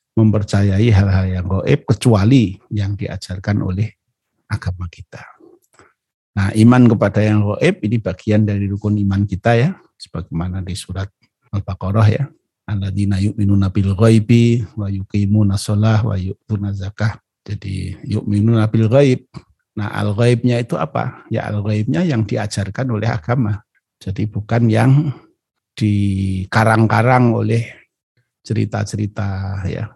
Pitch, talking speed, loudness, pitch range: 105 Hz, 110 wpm, -17 LUFS, 100-115 Hz